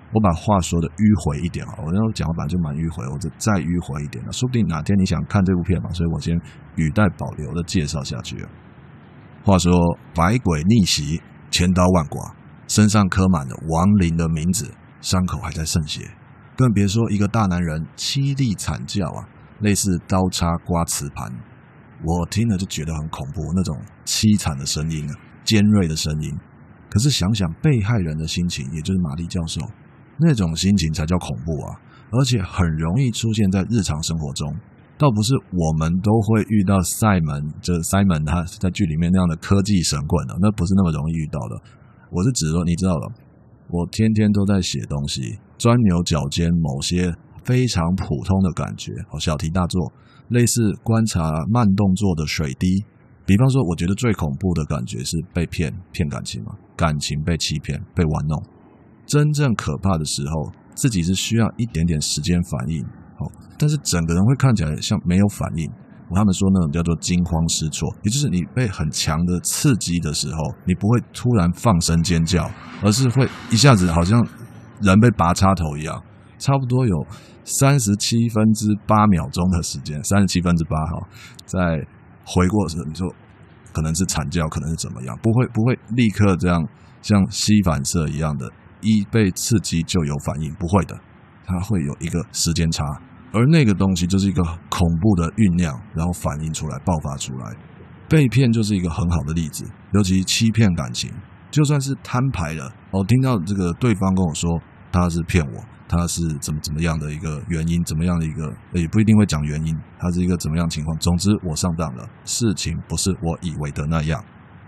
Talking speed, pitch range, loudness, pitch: 280 characters per minute, 80-105 Hz, -20 LUFS, 90 Hz